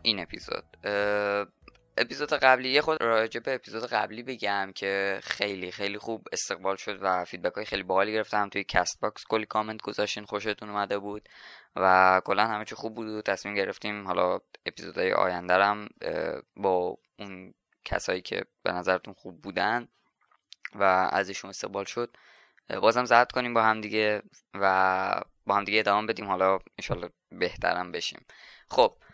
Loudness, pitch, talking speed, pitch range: -28 LUFS, 100 Hz, 150 wpm, 95-110 Hz